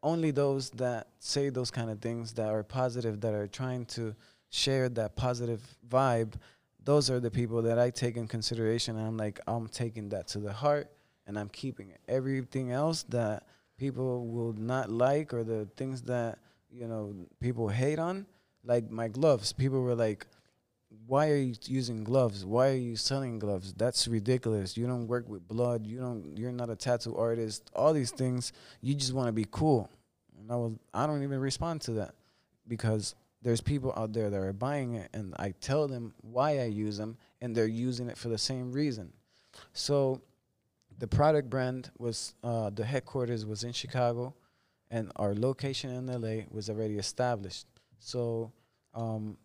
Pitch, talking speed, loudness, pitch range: 120 Hz, 185 wpm, -33 LUFS, 110-130 Hz